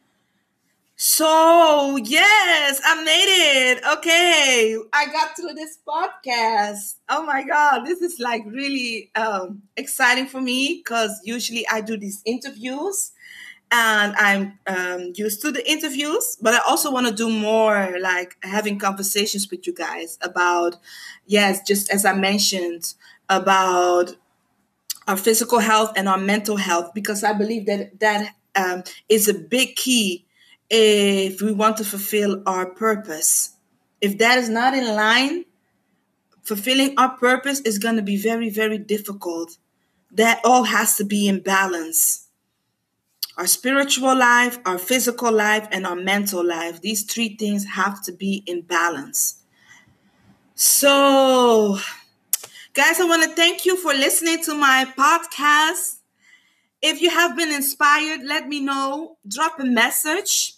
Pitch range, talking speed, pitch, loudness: 200-280 Hz, 140 wpm, 225 Hz, -19 LUFS